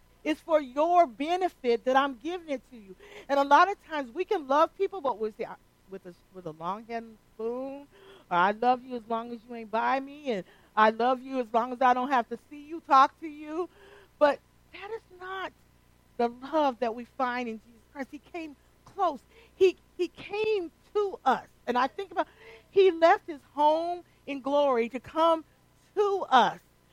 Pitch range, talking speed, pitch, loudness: 245-345 Hz, 205 wpm, 280 Hz, -28 LUFS